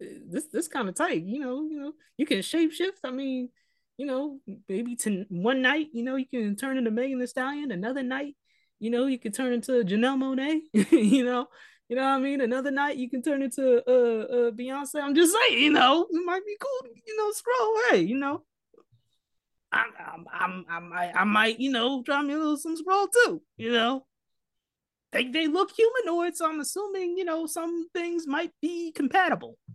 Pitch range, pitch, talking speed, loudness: 245-330 Hz, 275 Hz, 210 wpm, -26 LUFS